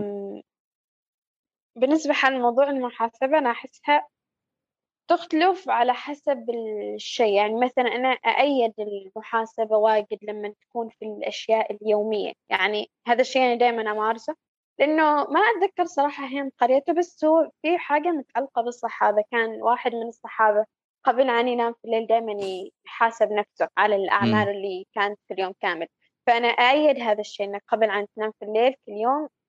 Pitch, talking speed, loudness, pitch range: 235 Hz, 140 wpm, -23 LUFS, 210-270 Hz